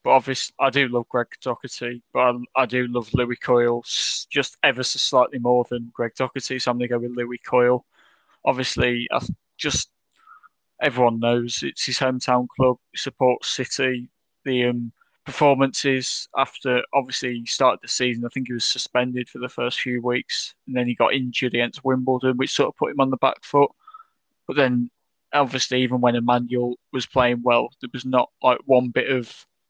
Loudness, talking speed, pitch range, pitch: -22 LUFS, 185 wpm, 120-130 Hz, 125 Hz